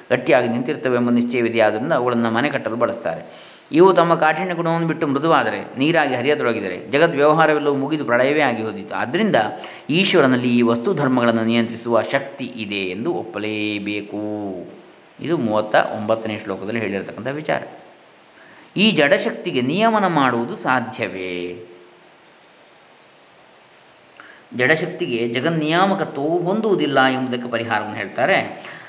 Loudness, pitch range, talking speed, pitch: -19 LUFS, 105-155 Hz, 105 wpm, 120 Hz